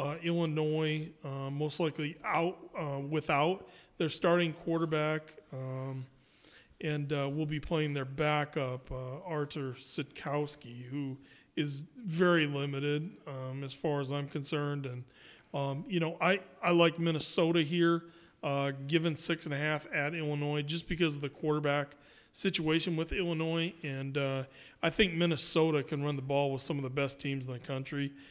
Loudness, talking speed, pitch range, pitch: -33 LUFS, 160 wpm, 140-165 Hz, 150 Hz